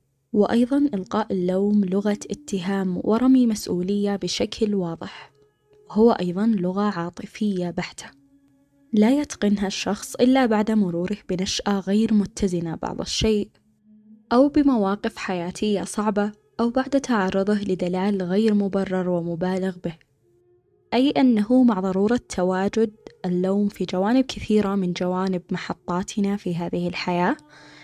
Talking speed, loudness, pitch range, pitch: 110 wpm, -23 LUFS, 180-215 Hz, 200 Hz